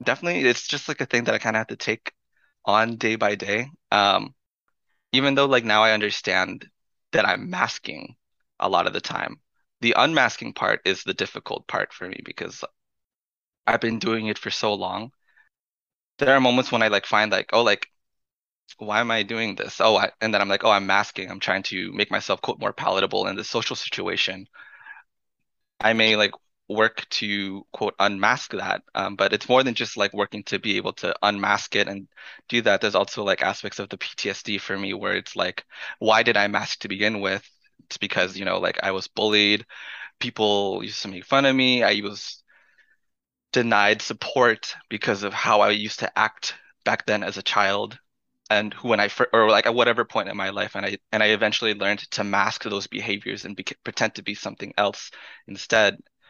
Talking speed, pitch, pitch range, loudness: 200 wpm, 110 Hz, 100-115 Hz, -22 LUFS